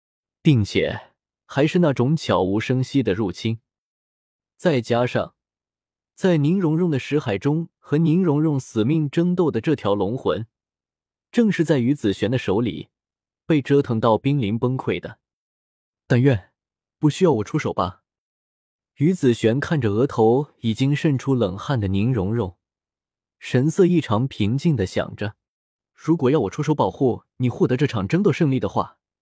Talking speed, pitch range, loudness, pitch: 225 characters per minute, 110-155 Hz, -21 LUFS, 130 Hz